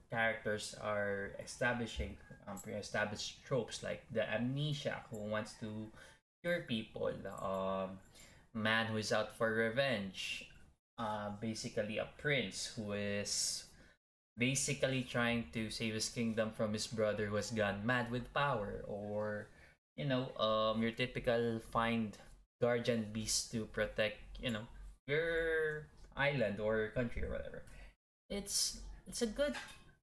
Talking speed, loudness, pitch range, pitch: 130 wpm, -38 LUFS, 110-125 Hz, 115 Hz